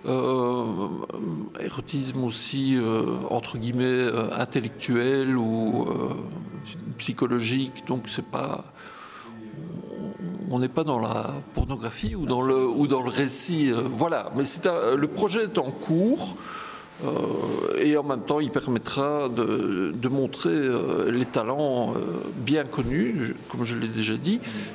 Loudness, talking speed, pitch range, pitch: -26 LUFS, 140 wpm, 120-150 Hz, 130 Hz